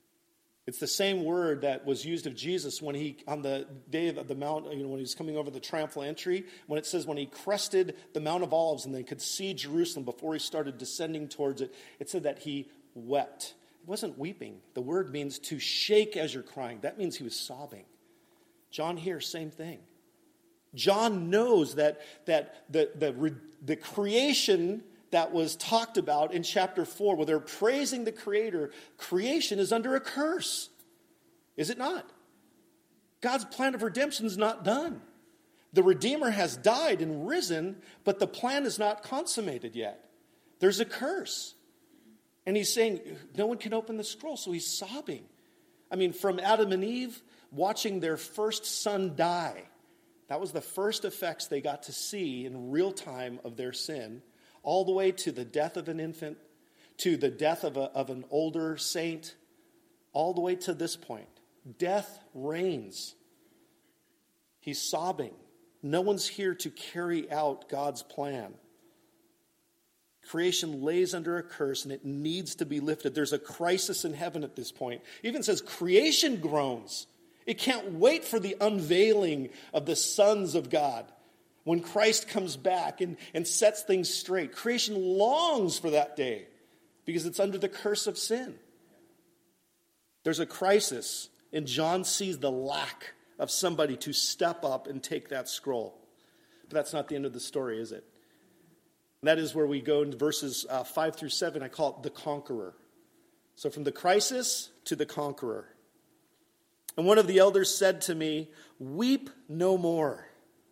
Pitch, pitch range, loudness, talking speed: 180 Hz, 150-230 Hz, -31 LUFS, 170 wpm